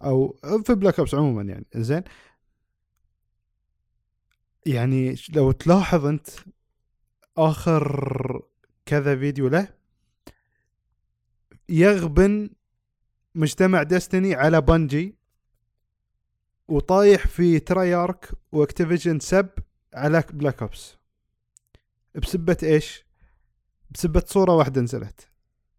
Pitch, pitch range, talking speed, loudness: 150 Hz, 120-175 Hz, 80 wpm, -21 LUFS